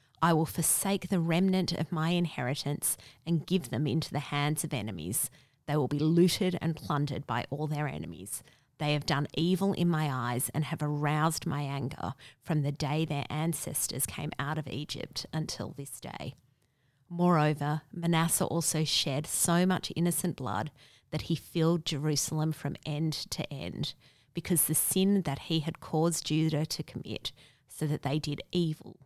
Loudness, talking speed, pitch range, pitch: -31 LUFS, 165 wpm, 140-165 Hz, 150 Hz